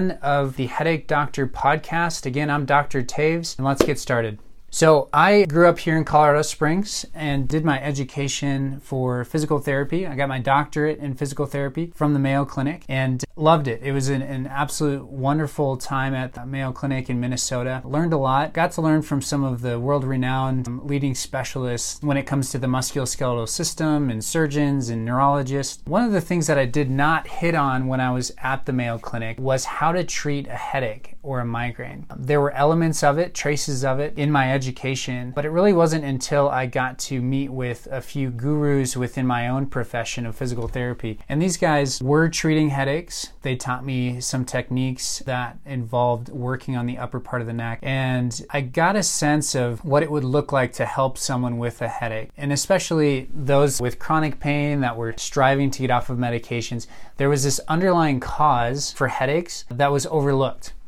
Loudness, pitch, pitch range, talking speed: -22 LUFS, 135 Hz, 125-150 Hz, 195 wpm